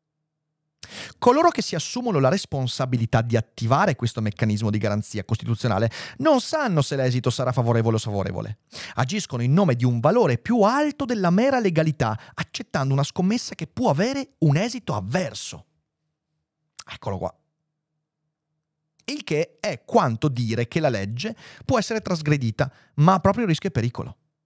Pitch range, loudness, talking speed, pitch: 120-190 Hz, -23 LUFS, 145 wpm, 155 Hz